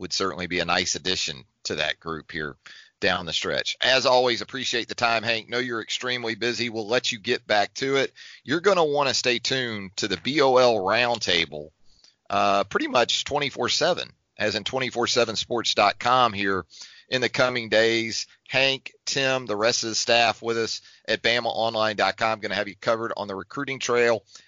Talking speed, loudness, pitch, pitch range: 180 wpm, -23 LUFS, 115 Hz, 105-125 Hz